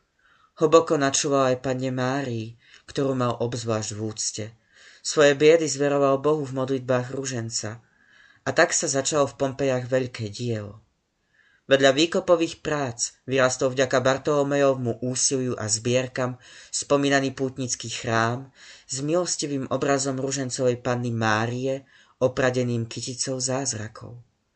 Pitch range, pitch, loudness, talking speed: 120-140 Hz, 130 Hz, -24 LUFS, 110 wpm